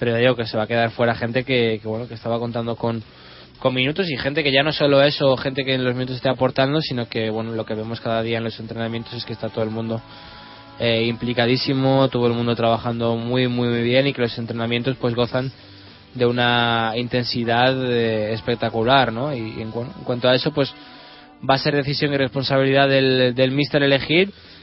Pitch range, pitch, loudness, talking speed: 115-135 Hz, 120 Hz, -20 LUFS, 220 wpm